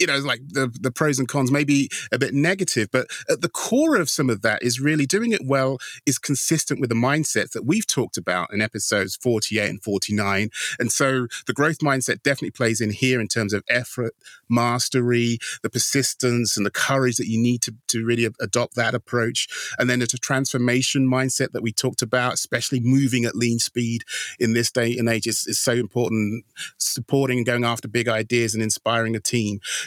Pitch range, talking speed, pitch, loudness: 115-135 Hz, 205 wpm, 120 Hz, -22 LUFS